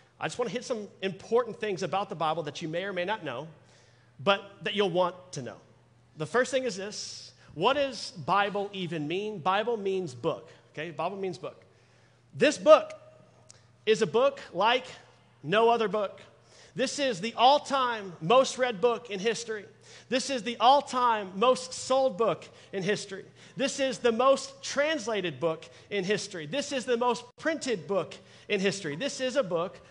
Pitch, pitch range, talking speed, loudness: 210 Hz, 175-250 Hz, 180 wpm, -28 LUFS